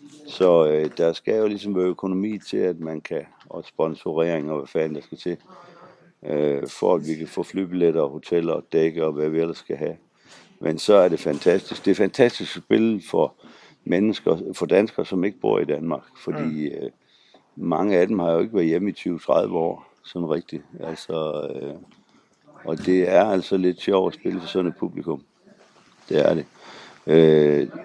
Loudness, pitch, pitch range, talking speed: -22 LUFS, 85 Hz, 80-95 Hz, 190 wpm